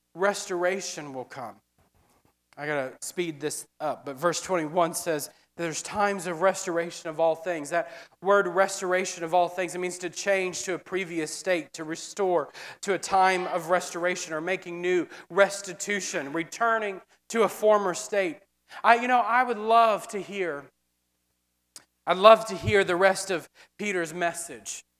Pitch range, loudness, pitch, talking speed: 165-195 Hz, -26 LUFS, 180 Hz, 160 wpm